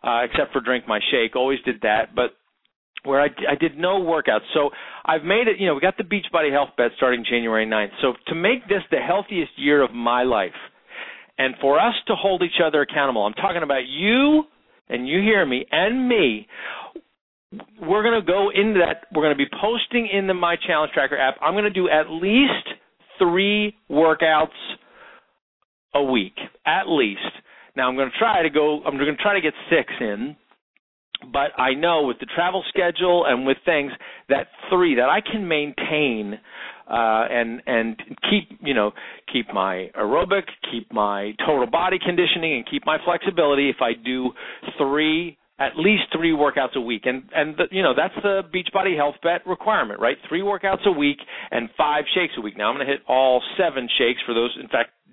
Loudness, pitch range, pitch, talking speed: -21 LUFS, 130-195 Hz, 155 Hz, 200 wpm